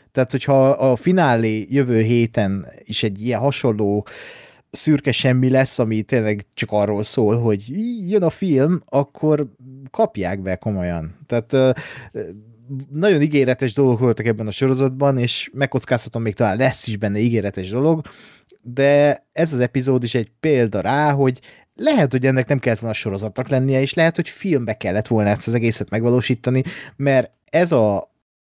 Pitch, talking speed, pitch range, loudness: 130 Hz, 155 wpm, 110-140 Hz, -19 LUFS